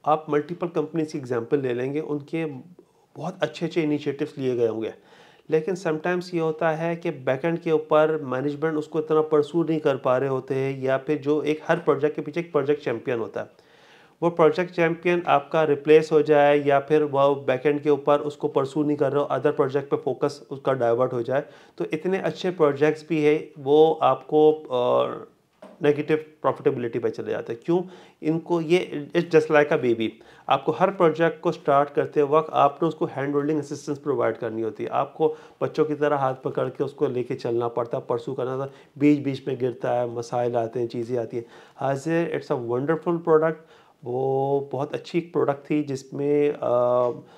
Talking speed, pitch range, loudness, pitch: 190 wpm, 140-160 Hz, -24 LUFS, 150 Hz